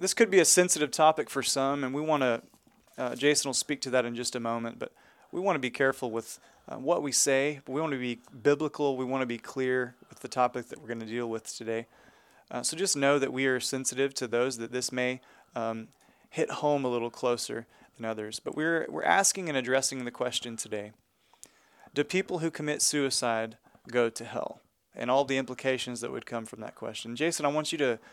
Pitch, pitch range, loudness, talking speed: 130 Hz, 120-145 Hz, -29 LUFS, 230 wpm